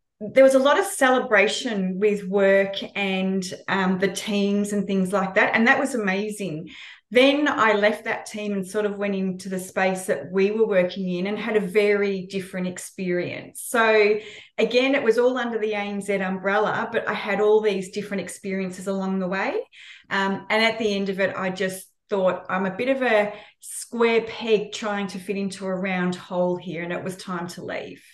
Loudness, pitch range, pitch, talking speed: -23 LUFS, 190-215 Hz, 200 Hz, 200 wpm